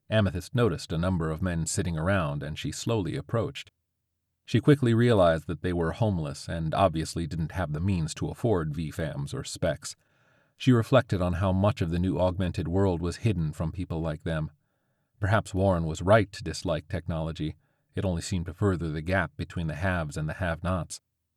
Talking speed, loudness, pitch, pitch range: 190 wpm, -28 LUFS, 90 Hz, 80-110 Hz